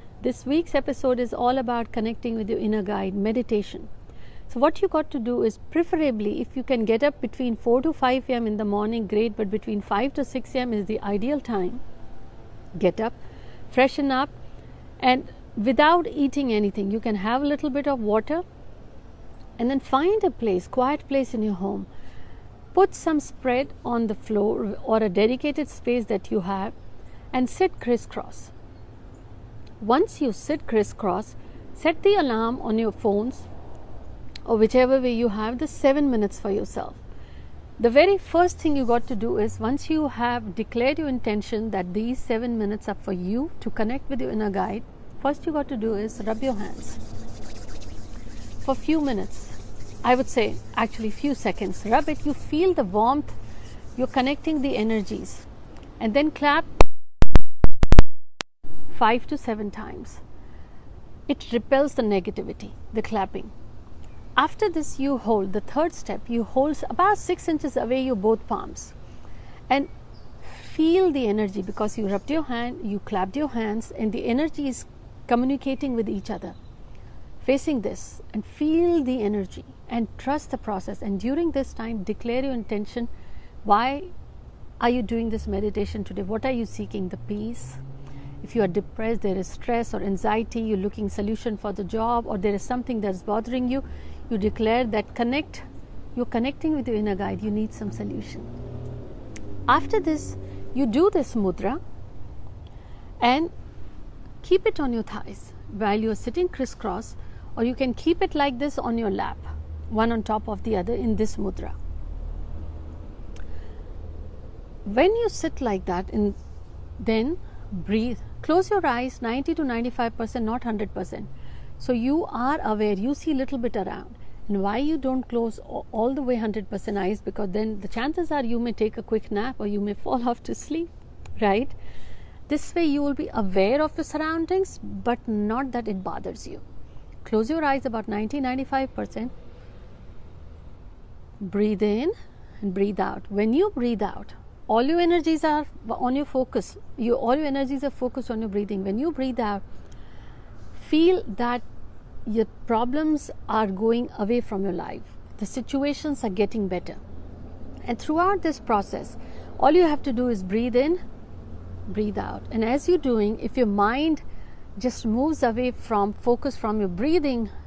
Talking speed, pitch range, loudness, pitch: 165 wpm, 205-270 Hz, -25 LUFS, 230 Hz